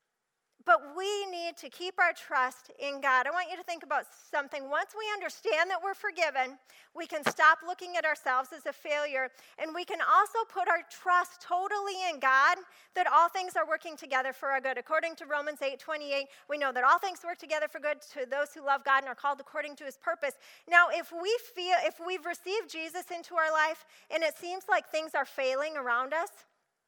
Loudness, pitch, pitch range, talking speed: -30 LUFS, 320 Hz, 285-355 Hz, 215 wpm